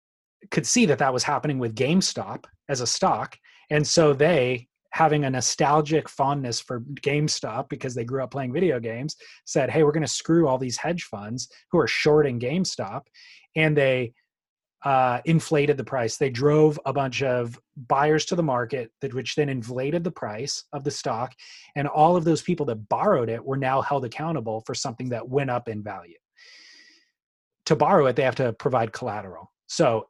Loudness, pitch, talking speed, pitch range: -24 LUFS, 140 Hz, 185 wpm, 125-155 Hz